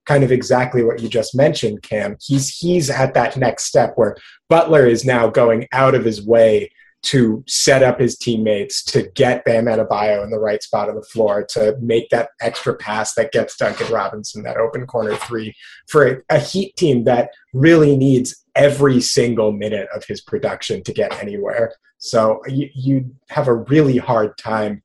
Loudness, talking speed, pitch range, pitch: -17 LUFS, 185 wpm, 115-140 Hz, 125 Hz